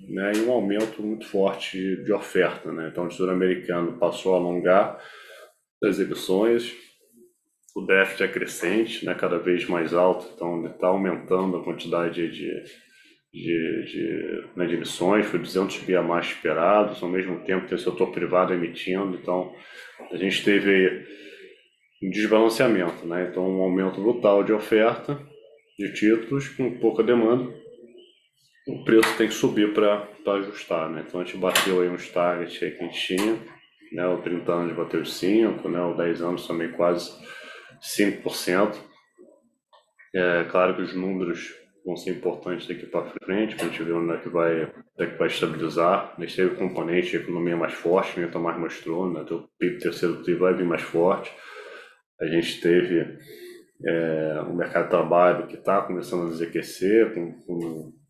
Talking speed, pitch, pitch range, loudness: 170 wpm, 90 Hz, 85-105 Hz, -24 LUFS